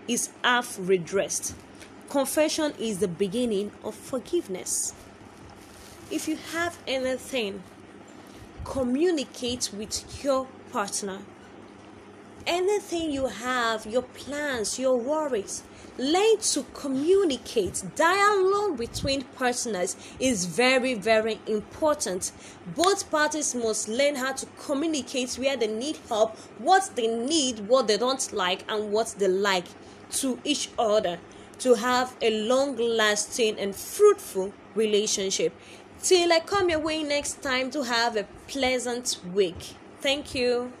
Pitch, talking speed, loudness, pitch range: 255 Hz, 120 wpm, -26 LUFS, 220-300 Hz